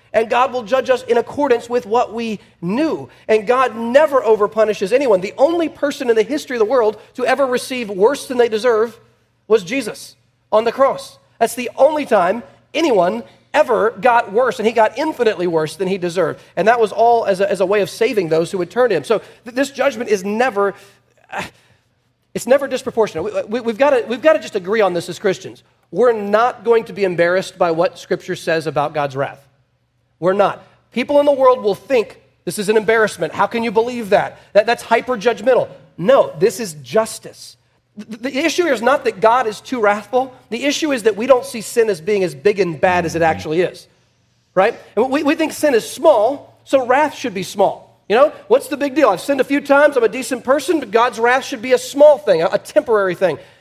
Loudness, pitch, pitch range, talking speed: -16 LUFS, 230 Hz, 195-265 Hz, 220 wpm